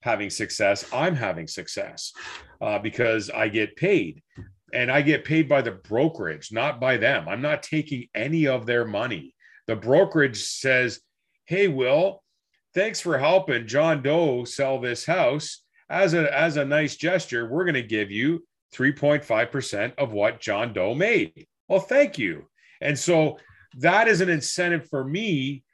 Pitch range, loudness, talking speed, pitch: 125-165 Hz, -23 LUFS, 160 wpm, 145 Hz